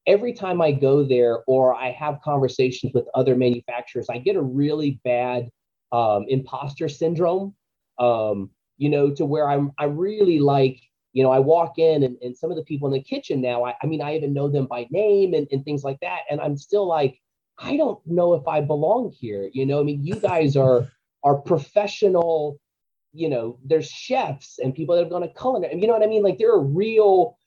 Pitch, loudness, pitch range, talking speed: 145 Hz, -22 LUFS, 130-175 Hz, 215 wpm